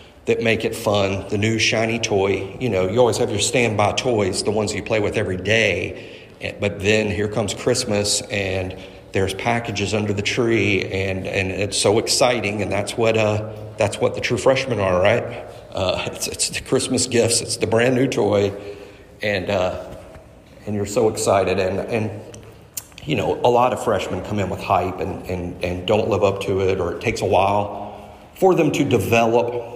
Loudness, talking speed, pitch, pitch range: -20 LUFS, 190 wpm, 105 Hz, 100-115 Hz